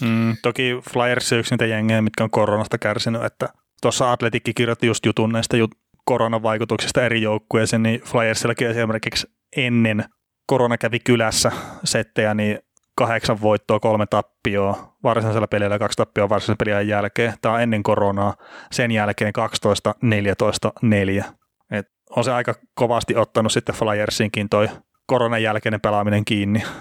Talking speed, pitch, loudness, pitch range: 140 wpm, 110 Hz, -20 LUFS, 105-115 Hz